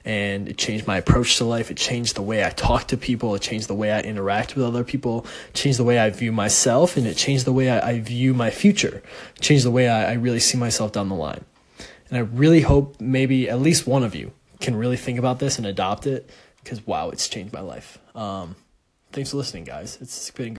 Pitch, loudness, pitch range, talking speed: 120 Hz, -21 LUFS, 110-130 Hz, 240 wpm